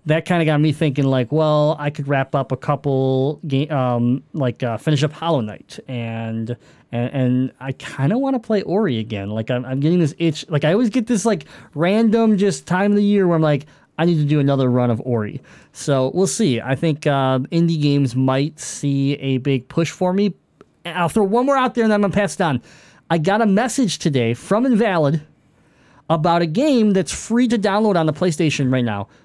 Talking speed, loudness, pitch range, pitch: 225 wpm, -19 LUFS, 130-190 Hz, 150 Hz